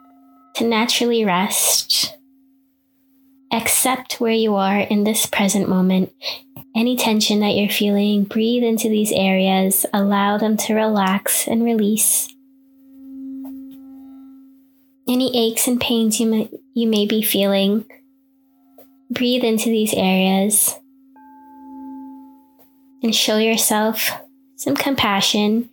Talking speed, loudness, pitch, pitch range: 105 wpm, -17 LUFS, 235 Hz, 215-270 Hz